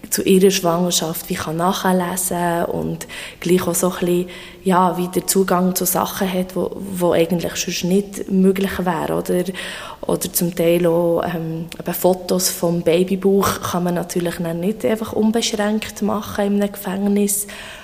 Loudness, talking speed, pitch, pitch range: -19 LUFS, 150 wpm, 180 Hz, 175-195 Hz